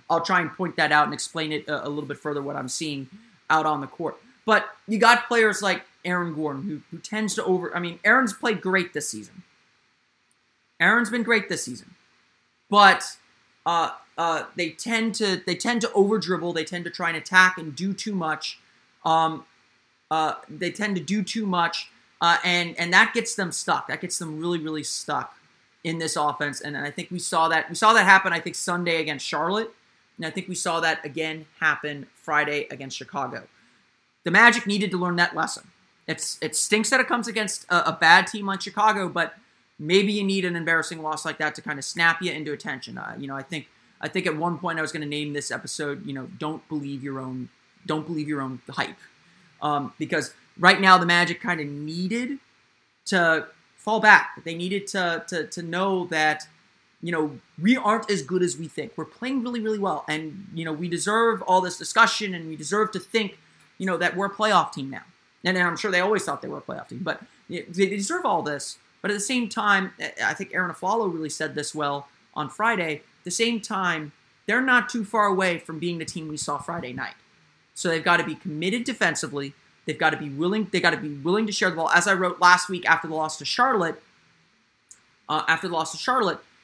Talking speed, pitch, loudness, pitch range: 220 wpm, 175 Hz, -23 LUFS, 155-195 Hz